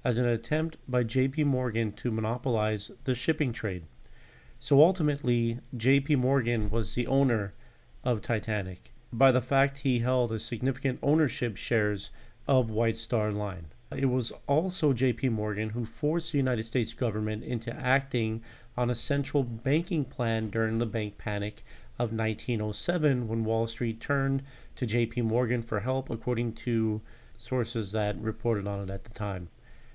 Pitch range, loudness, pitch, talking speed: 110-130 Hz, -29 LUFS, 120 Hz, 150 wpm